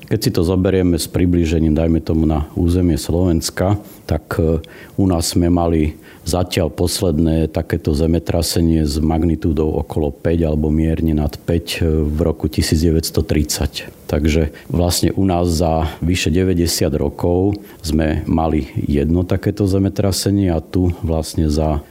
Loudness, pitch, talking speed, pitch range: -17 LUFS, 85 Hz, 130 wpm, 80-90 Hz